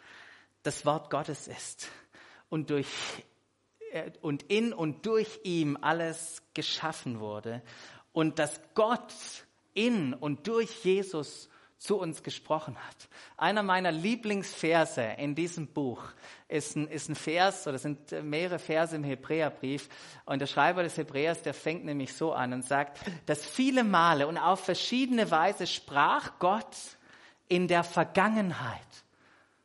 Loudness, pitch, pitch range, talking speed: -31 LUFS, 160 Hz, 145-185 Hz, 135 wpm